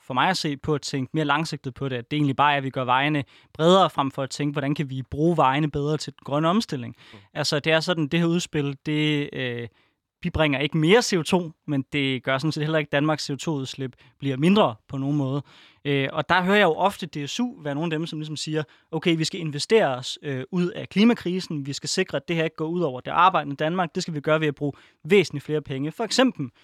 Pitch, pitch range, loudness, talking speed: 150 Hz, 140-165 Hz, -24 LUFS, 265 wpm